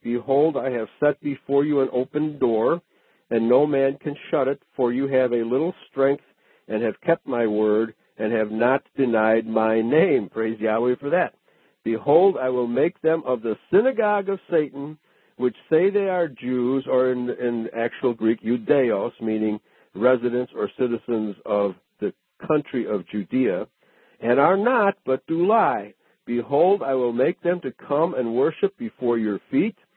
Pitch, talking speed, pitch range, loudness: 125 Hz, 170 wpm, 115-145 Hz, -23 LUFS